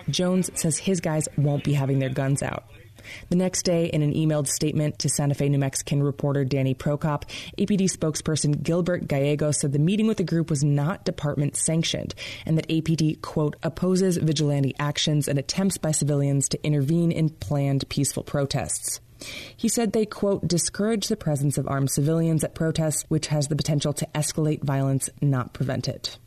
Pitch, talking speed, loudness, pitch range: 150 Hz, 180 wpm, -24 LUFS, 140-165 Hz